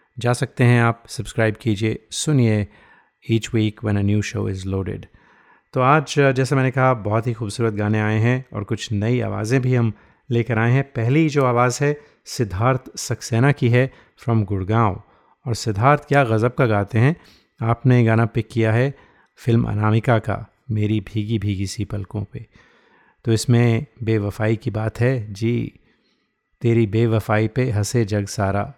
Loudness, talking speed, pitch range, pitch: -20 LUFS, 165 wpm, 110-125 Hz, 115 Hz